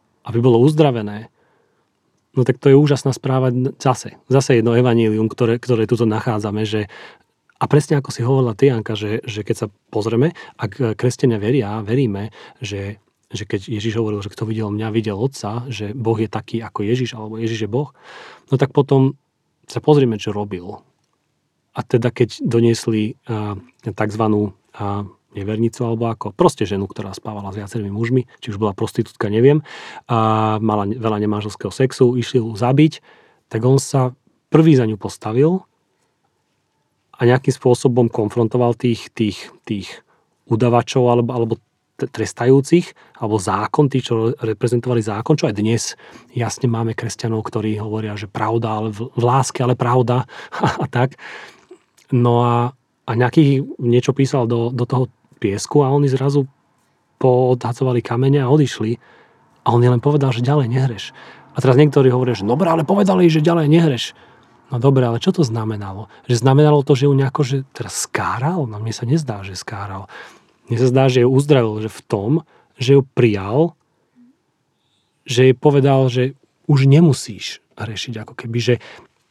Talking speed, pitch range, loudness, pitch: 160 wpm, 110-135 Hz, -18 LUFS, 120 Hz